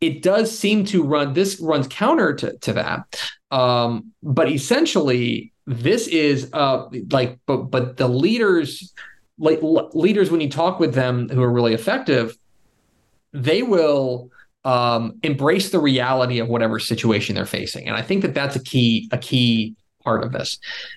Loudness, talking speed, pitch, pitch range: -20 LUFS, 160 wpm, 135 Hz, 120-165 Hz